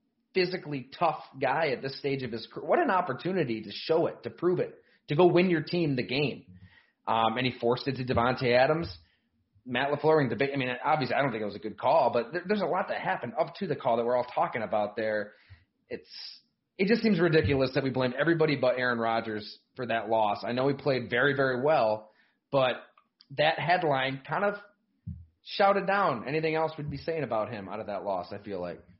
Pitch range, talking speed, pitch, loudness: 115-160 Hz, 225 wpm, 130 Hz, -28 LUFS